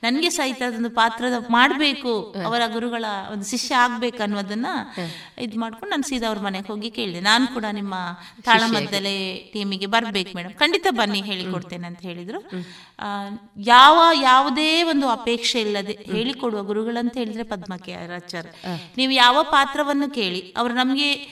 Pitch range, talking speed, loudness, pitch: 200-250 Hz, 130 wpm, -20 LUFS, 225 Hz